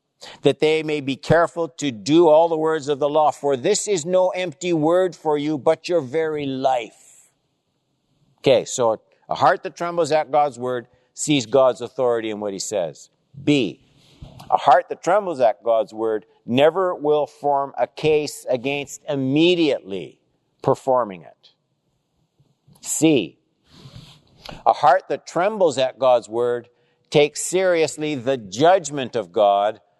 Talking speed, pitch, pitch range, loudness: 145 wpm, 150 Hz, 130-160 Hz, -20 LUFS